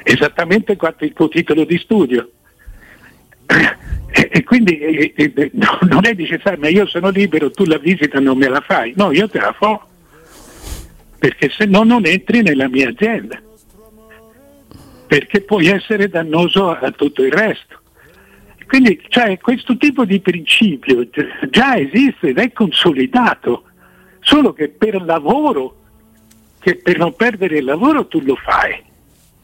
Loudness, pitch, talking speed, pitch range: -14 LUFS, 195 Hz, 145 wpm, 155-220 Hz